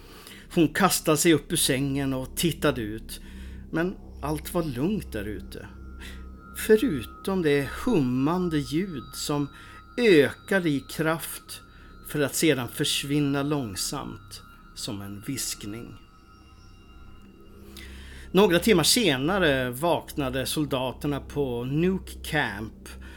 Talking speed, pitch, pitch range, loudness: 100 wpm, 130 Hz, 100-150 Hz, -25 LUFS